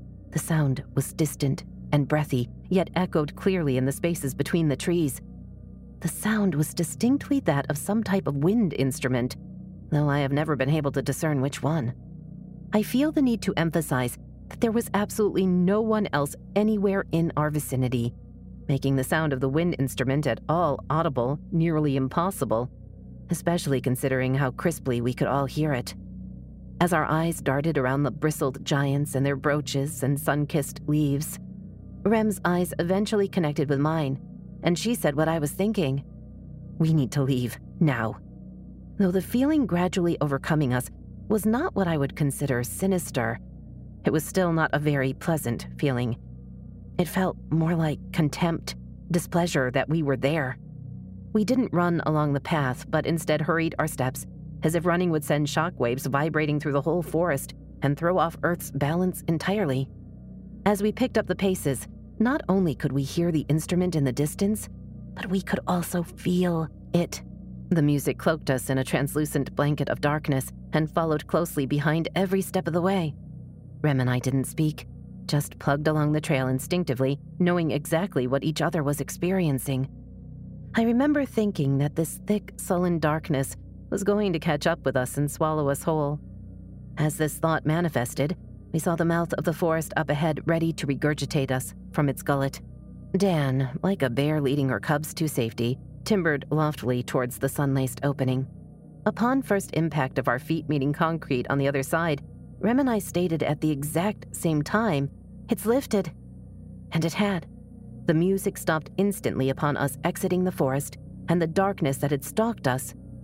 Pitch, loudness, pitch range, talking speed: 155 Hz, -26 LUFS, 135-175 Hz, 170 wpm